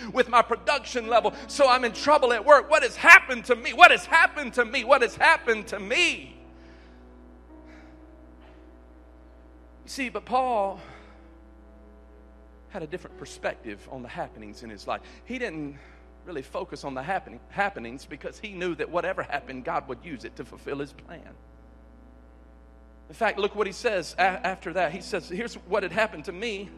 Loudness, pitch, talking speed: -23 LUFS, 195 Hz, 170 wpm